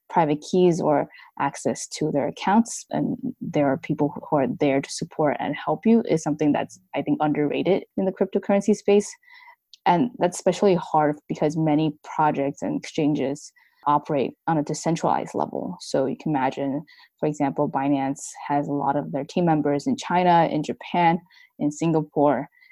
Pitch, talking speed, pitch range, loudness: 155 Hz, 165 wpm, 145-190 Hz, -23 LUFS